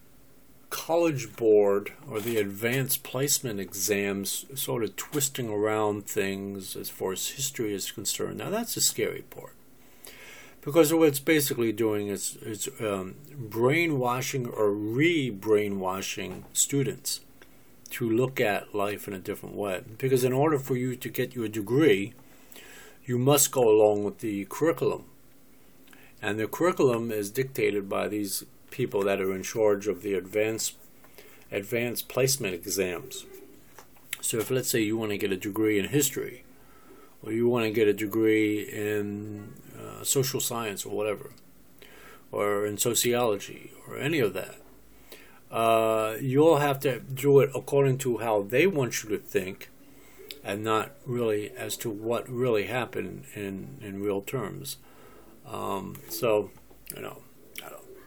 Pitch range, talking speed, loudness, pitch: 105-135 Hz, 145 wpm, -27 LUFS, 115 Hz